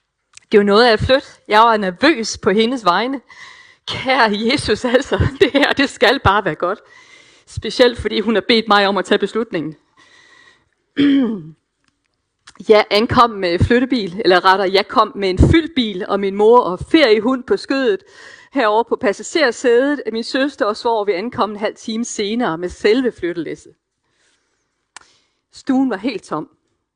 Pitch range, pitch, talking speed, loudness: 210-275 Hz, 230 Hz, 160 wpm, -16 LUFS